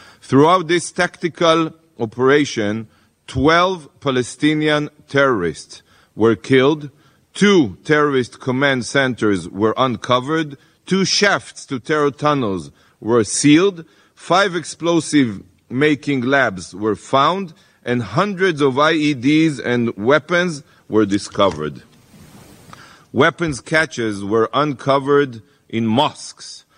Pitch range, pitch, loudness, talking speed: 115-160 Hz, 140 Hz, -17 LUFS, 95 wpm